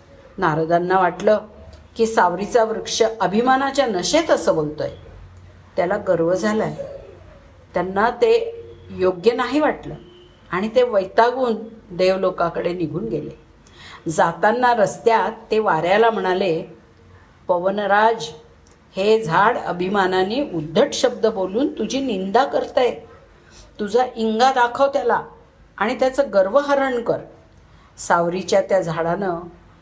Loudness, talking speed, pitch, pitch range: -19 LUFS, 100 wpm, 200 Hz, 170-240 Hz